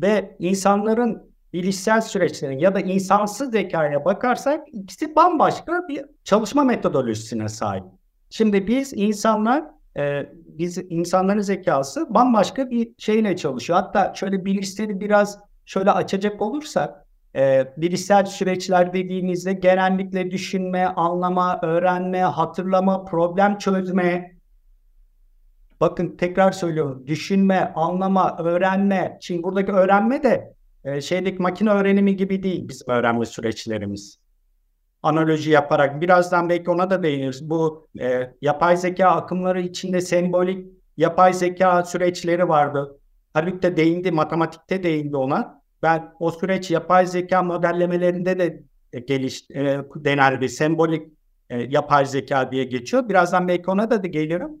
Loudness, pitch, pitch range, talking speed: -21 LUFS, 180 Hz, 155-195 Hz, 120 wpm